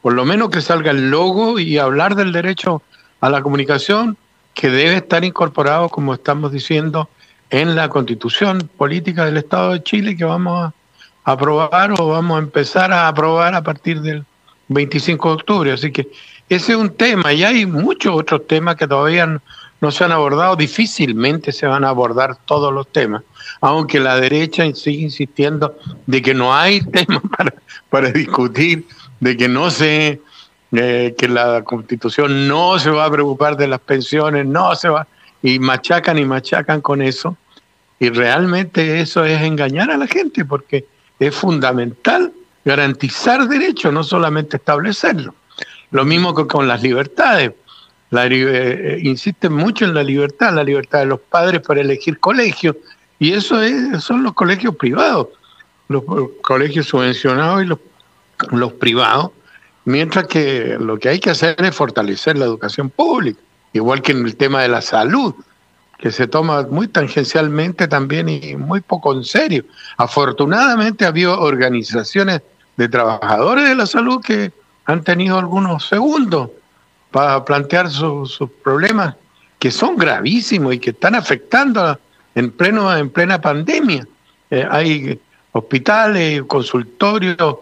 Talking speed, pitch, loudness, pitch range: 155 wpm, 155 Hz, -15 LUFS, 135-180 Hz